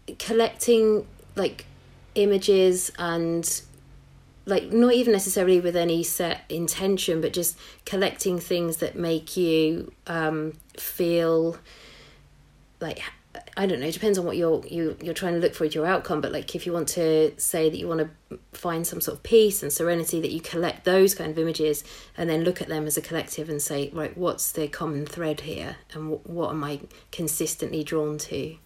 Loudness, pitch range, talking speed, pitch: -25 LUFS, 155-180 Hz, 185 wpm, 165 Hz